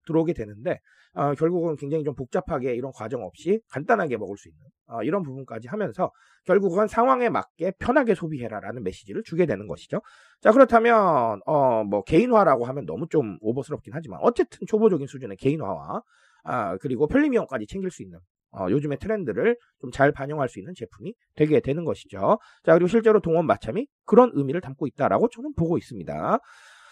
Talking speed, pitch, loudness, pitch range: 410 characters per minute, 165 Hz, -24 LUFS, 135-220 Hz